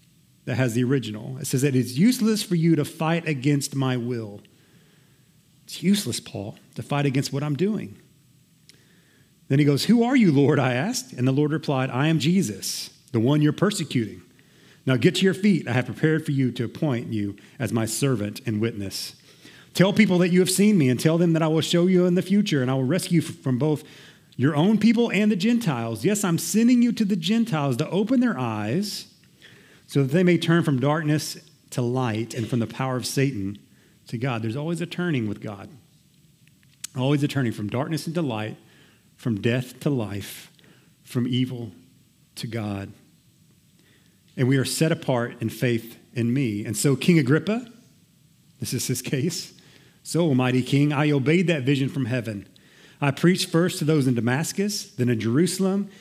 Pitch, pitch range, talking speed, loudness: 145 Hz, 125-170 Hz, 190 wpm, -23 LUFS